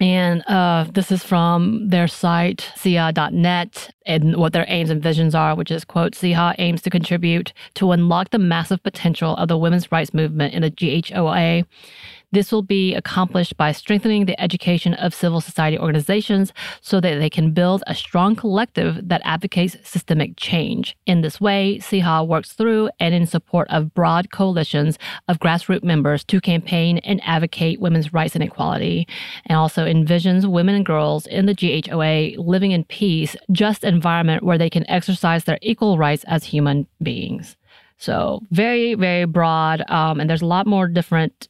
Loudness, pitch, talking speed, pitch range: -19 LUFS, 175 Hz, 170 wpm, 160-190 Hz